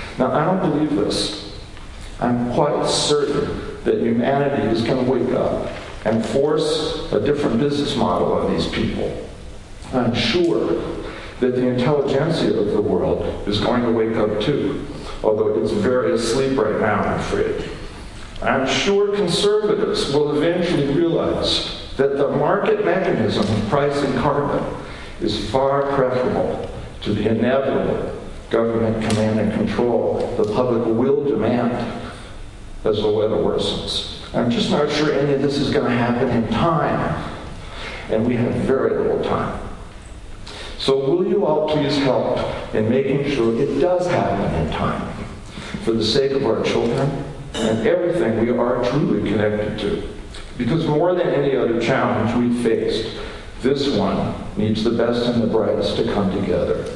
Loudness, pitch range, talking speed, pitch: -20 LUFS, 110-145 Hz, 150 wpm, 125 Hz